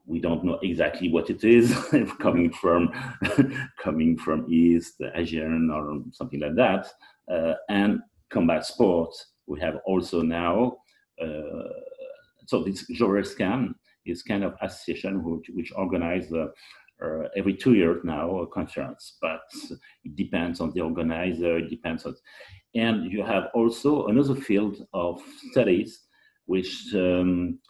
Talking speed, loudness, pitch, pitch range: 140 wpm, -26 LUFS, 95 Hz, 85-125 Hz